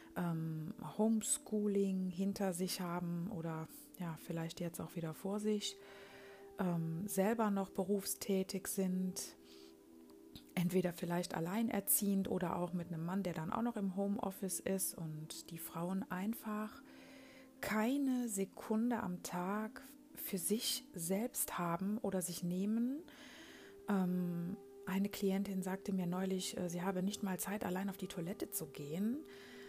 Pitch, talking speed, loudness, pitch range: 195 Hz, 130 wpm, -39 LUFS, 175-210 Hz